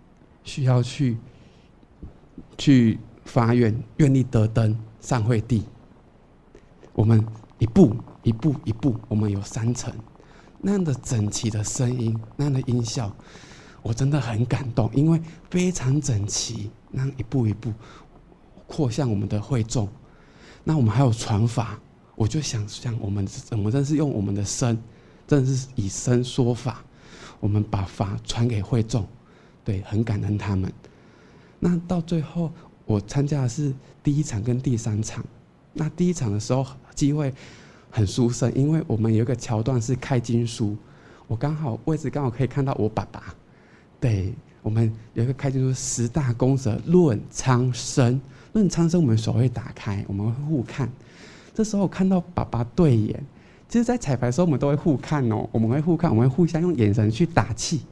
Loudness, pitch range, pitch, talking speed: -24 LUFS, 110-140 Hz, 125 Hz, 240 characters per minute